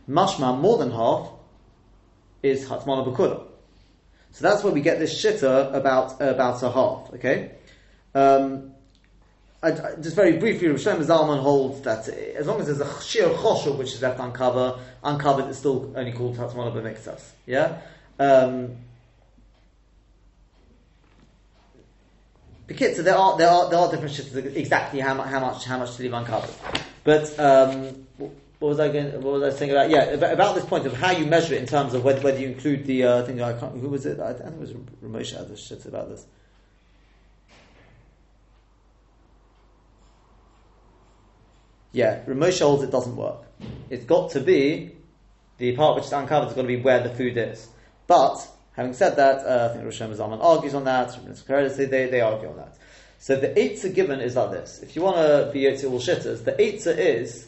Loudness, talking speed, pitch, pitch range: -22 LUFS, 180 wpm, 135 Hz, 125-145 Hz